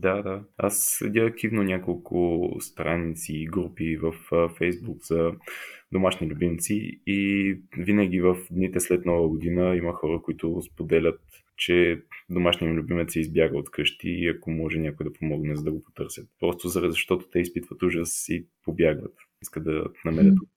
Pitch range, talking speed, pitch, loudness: 80-95 Hz, 150 wpm, 85 Hz, -26 LUFS